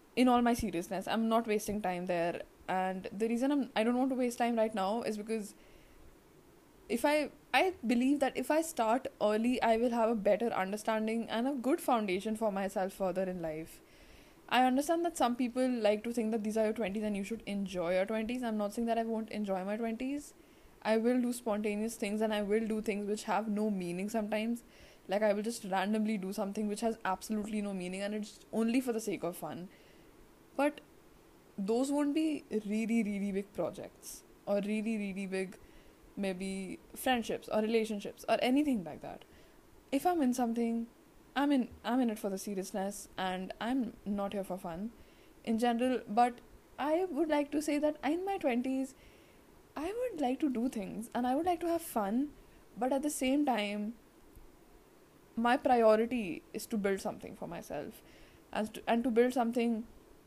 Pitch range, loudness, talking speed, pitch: 205-250 Hz, -34 LUFS, 190 wpm, 225 Hz